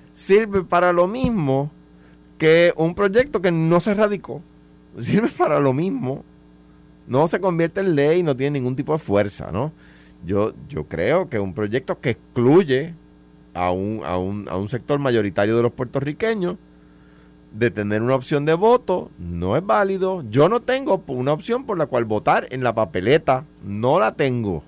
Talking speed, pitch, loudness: 170 wpm, 130 Hz, -20 LUFS